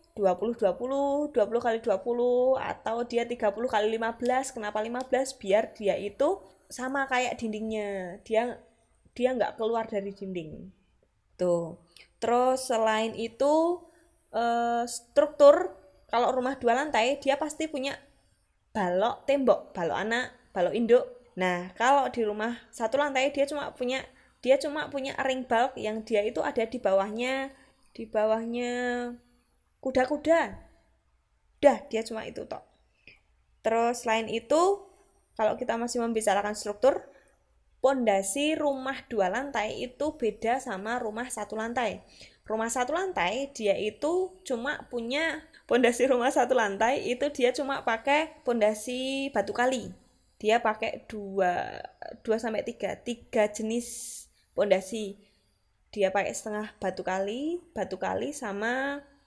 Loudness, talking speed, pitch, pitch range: -28 LUFS, 125 wpm, 240 Hz, 220-275 Hz